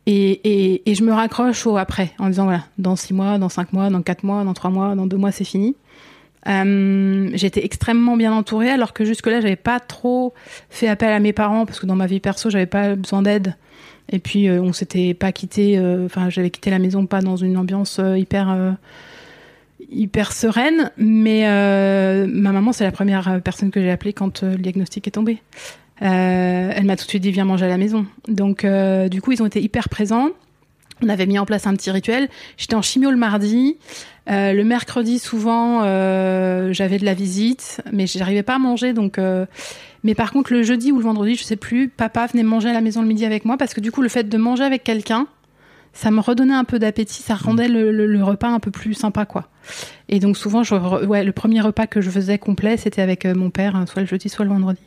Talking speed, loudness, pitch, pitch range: 235 wpm, -18 LUFS, 205 Hz, 190-225 Hz